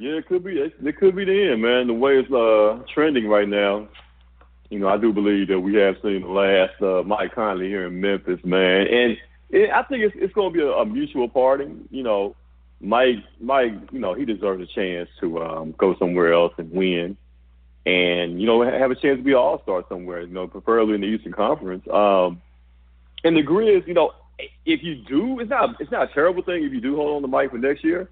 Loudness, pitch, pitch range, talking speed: -21 LUFS, 105 Hz, 90-145 Hz, 235 wpm